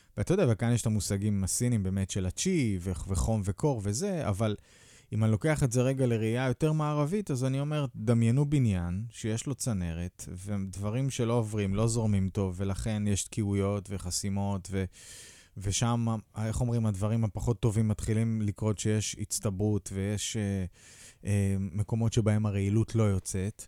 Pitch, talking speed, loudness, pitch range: 110 Hz, 155 wpm, -30 LUFS, 100-120 Hz